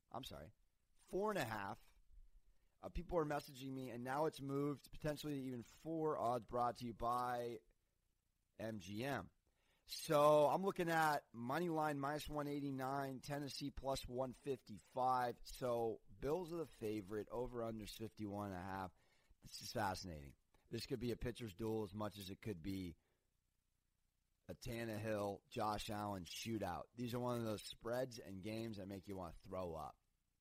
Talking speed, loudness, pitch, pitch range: 170 wpm, -44 LUFS, 115 Hz, 100-135 Hz